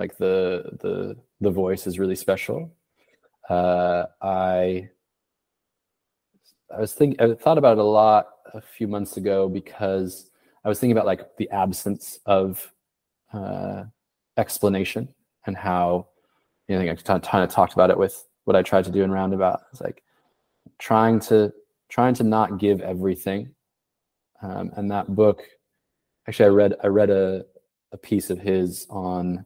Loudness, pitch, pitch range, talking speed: -22 LUFS, 95 Hz, 95-105 Hz, 155 wpm